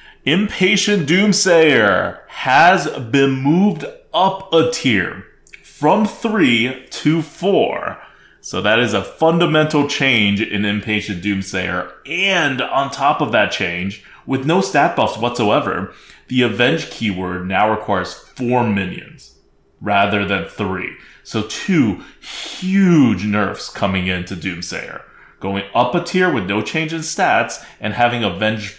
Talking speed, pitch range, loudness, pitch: 125 wpm, 100-165 Hz, -17 LUFS, 125 Hz